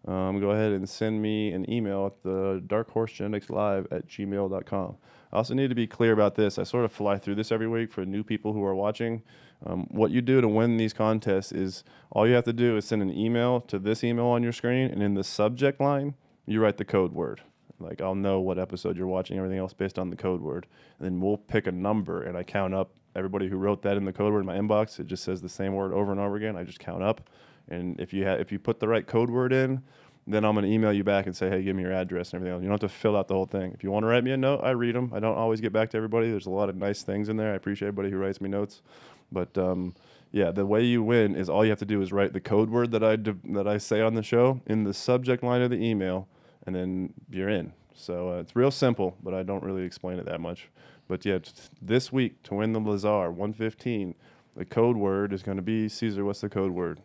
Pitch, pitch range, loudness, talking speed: 105 Hz, 95-115 Hz, -28 LUFS, 275 wpm